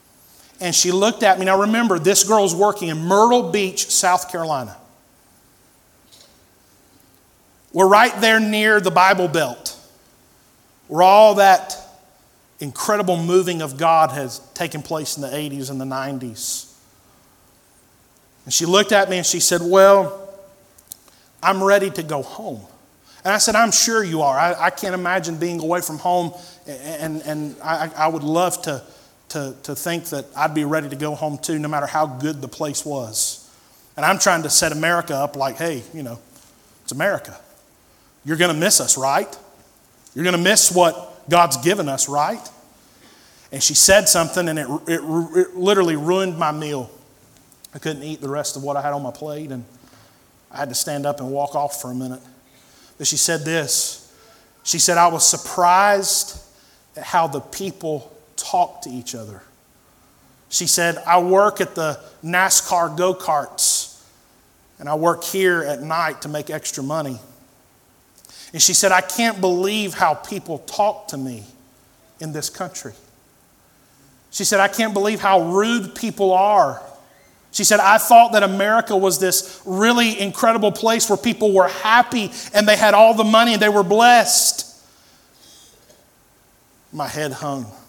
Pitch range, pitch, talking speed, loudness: 145-195 Hz, 170 Hz, 165 wpm, -17 LUFS